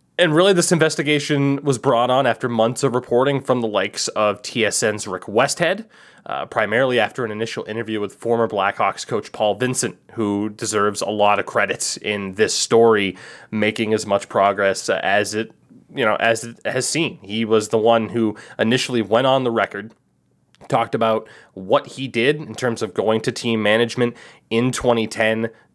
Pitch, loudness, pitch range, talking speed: 115 Hz, -19 LUFS, 105-125 Hz, 175 wpm